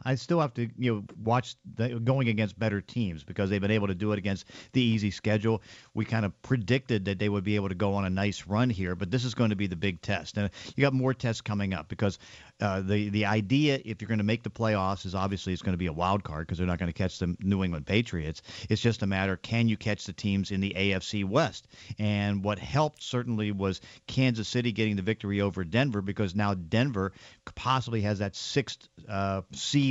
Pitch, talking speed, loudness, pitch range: 105 Hz, 245 wpm, -29 LUFS, 95-115 Hz